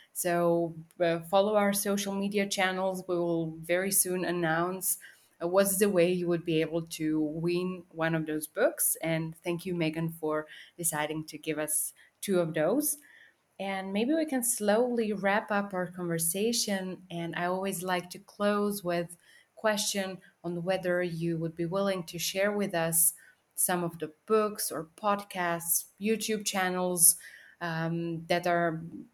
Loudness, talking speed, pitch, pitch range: -29 LUFS, 155 wpm, 175 Hz, 165-195 Hz